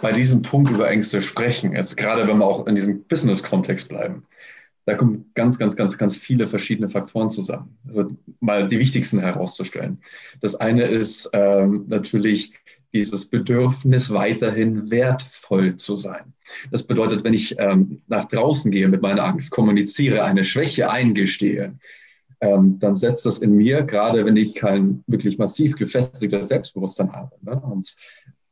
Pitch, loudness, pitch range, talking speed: 105 Hz, -20 LUFS, 100-120 Hz, 155 wpm